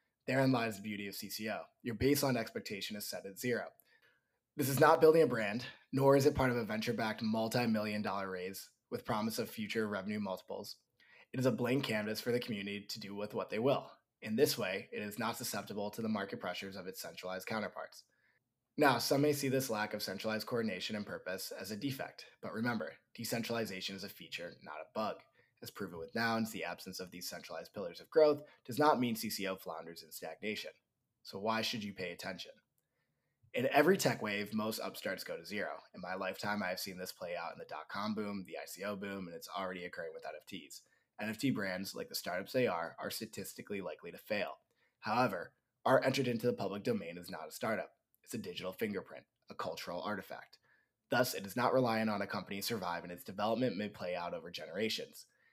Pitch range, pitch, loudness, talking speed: 95-120 Hz, 105 Hz, -37 LUFS, 210 wpm